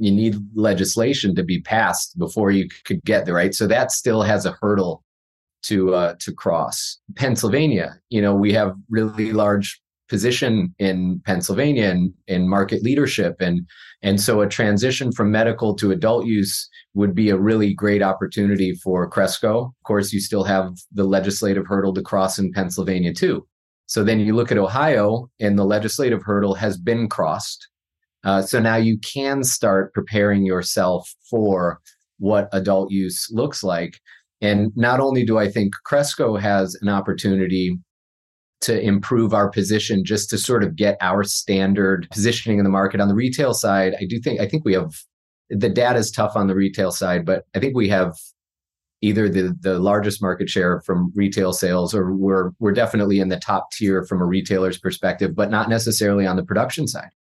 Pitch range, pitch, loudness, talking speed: 95-110 Hz, 100 Hz, -20 LUFS, 180 wpm